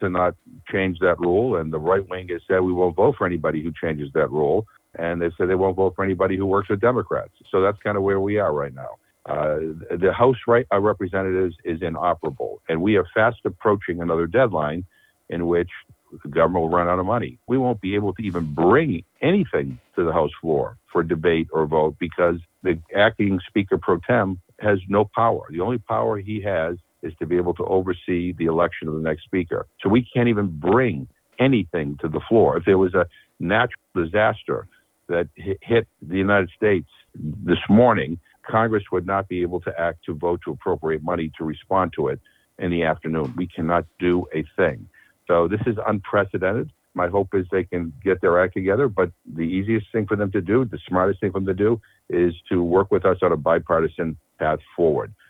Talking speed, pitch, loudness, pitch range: 205 wpm, 90 Hz, -22 LUFS, 85-100 Hz